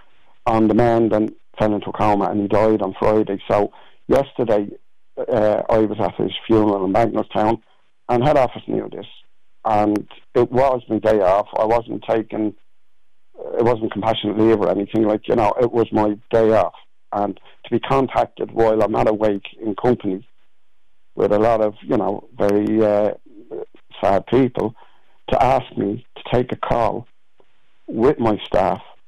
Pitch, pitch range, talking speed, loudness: 110 Hz, 105-115 Hz, 165 wpm, -19 LUFS